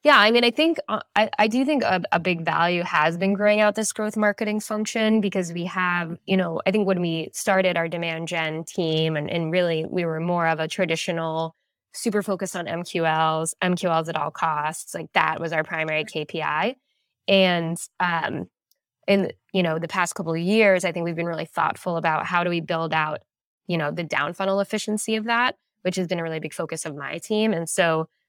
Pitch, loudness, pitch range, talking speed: 175 Hz, -23 LUFS, 165-205 Hz, 215 wpm